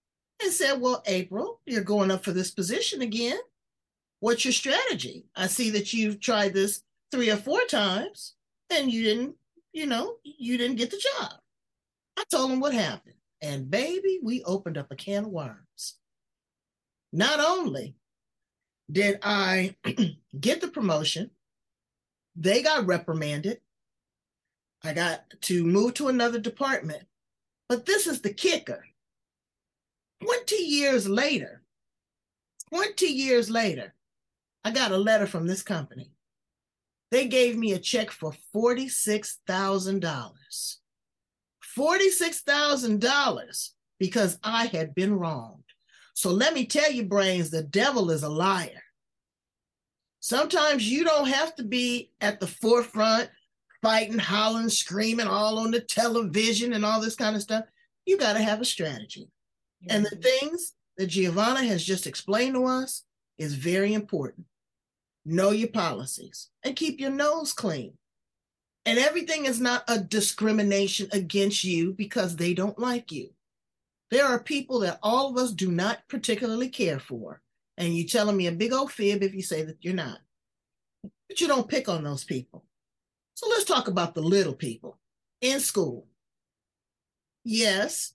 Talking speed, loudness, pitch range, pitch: 145 wpm, -26 LUFS, 190-260 Hz, 220 Hz